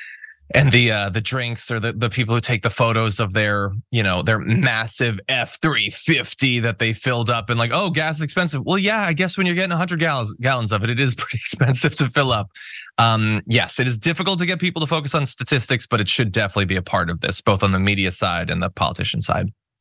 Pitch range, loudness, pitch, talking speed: 110-150 Hz, -19 LUFS, 120 Hz, 240 wpm